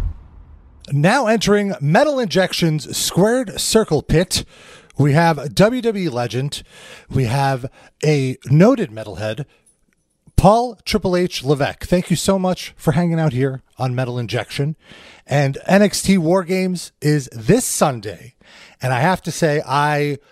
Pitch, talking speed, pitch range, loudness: 155 Hz, 135 wpm, 130-190 Hz, -18 LUFS